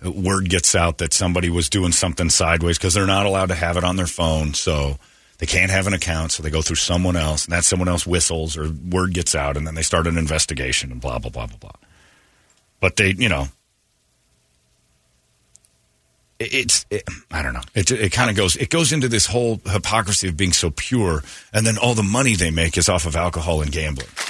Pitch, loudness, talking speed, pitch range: 85 Hz, -19 LUFS, 220 wpm, 80-95 Hz